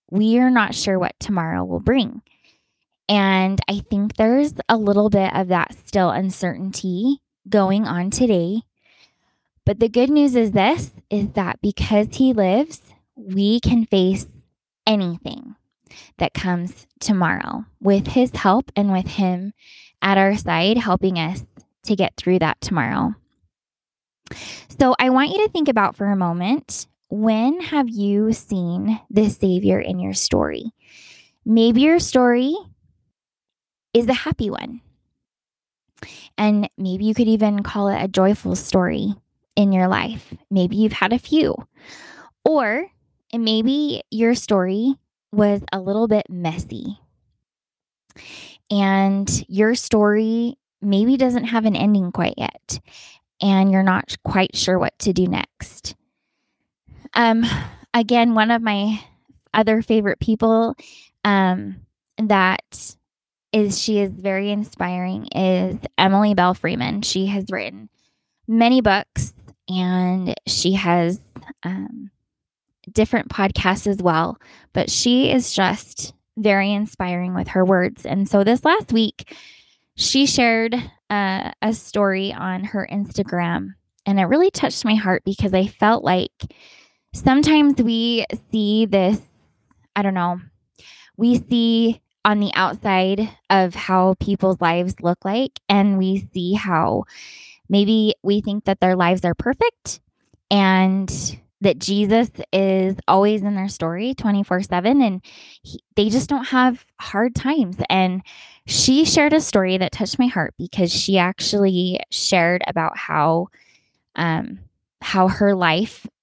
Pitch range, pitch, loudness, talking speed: 185-230 Hz, 205 Hz, -19 LUFS, 135 wpm